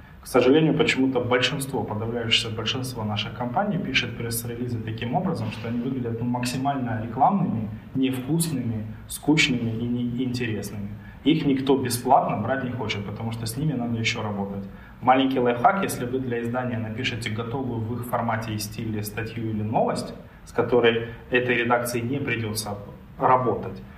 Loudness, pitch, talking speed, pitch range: -25 LUFS, 120 Hz, 145 wpm, 110-125 Hz